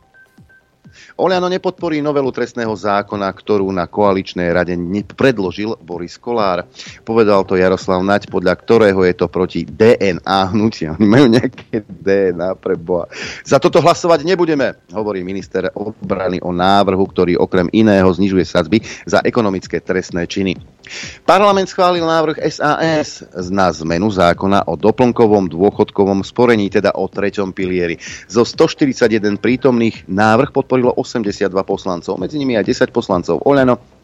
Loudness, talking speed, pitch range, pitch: -15 LUFS, 130 wpm, 95-125 Hz, 100 Hz